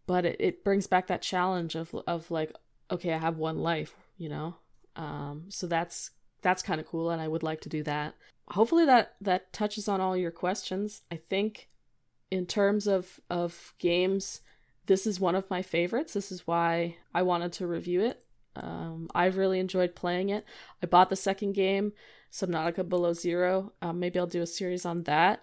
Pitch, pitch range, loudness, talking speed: 180 Hz, 170-190 Hz, -30 LUFS, 195 wpm